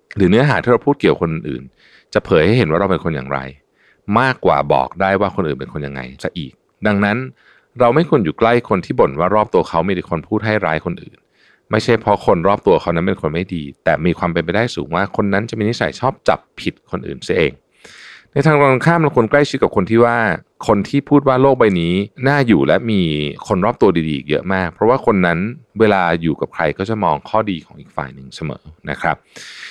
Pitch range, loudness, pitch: 85-115 Hz, -16 LUFS, 100 Hz